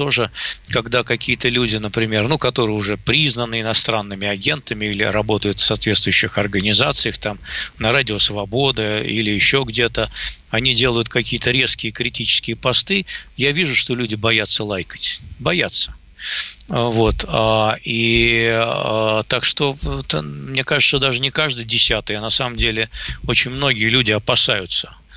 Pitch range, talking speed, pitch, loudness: 110-125 Hz, 130 wpm, 115 Hz, -17 LUFS